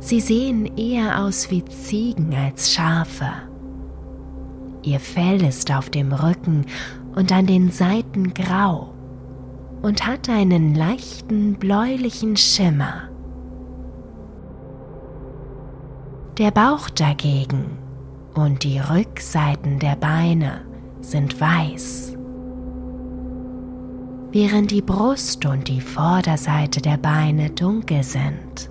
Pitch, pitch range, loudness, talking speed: 145 Hz, 130-185 Hz, -19 LUFS, 95 wpm